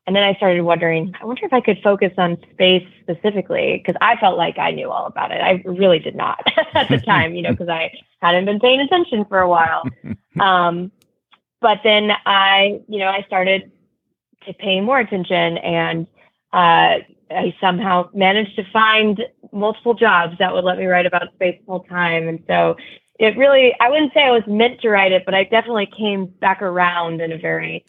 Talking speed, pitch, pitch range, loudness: 200 wpm, 190 Hz, 180-215 Hz, -16 LUFS